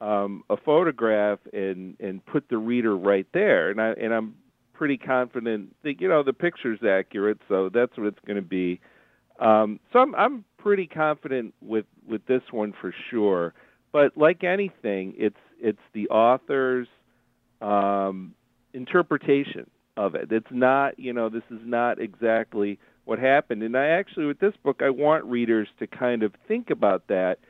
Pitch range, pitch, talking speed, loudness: 105-140 Hz, 120 Hz, 170 wpm, -24 LUFS